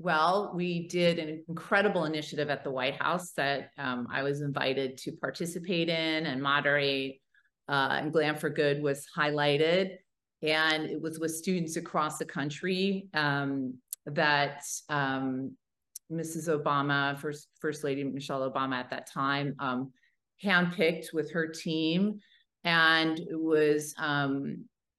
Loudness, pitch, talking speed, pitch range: -30 LUFS, 150 Hz, 135 wpm, 140-165 Hz